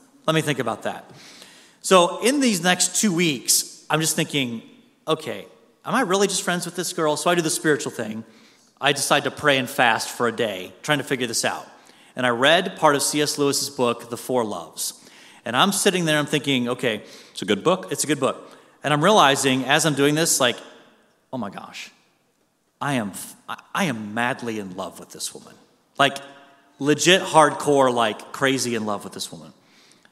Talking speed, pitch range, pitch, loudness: 200 wpm, 125-170 Hz, 145 Hz, -21 LUFS